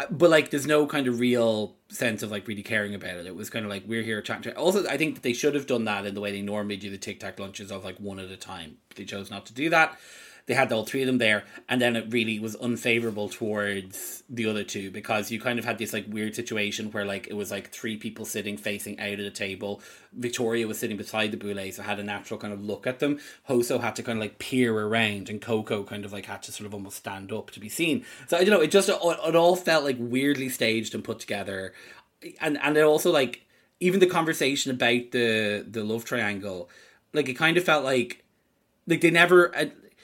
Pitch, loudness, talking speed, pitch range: 110 Hz, -26 LUFS, 255 wpm, 100-130 Hz